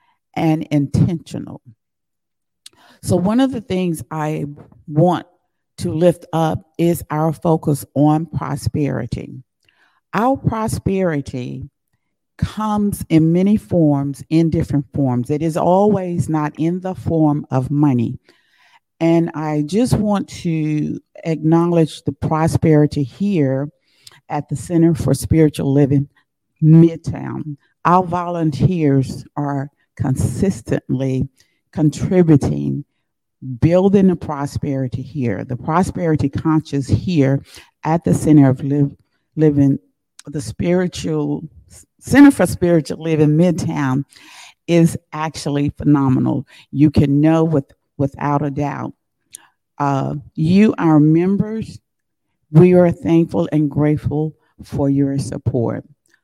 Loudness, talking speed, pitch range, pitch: -17 LUFS, 105 wpm, 140-165 Hz, 150 Hz